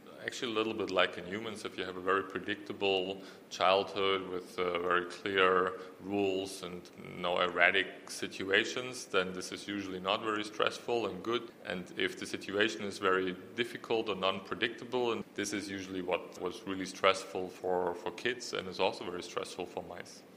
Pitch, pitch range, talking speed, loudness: 95 Hz, 90-100 Hz, 175 wpm, -34 LUFS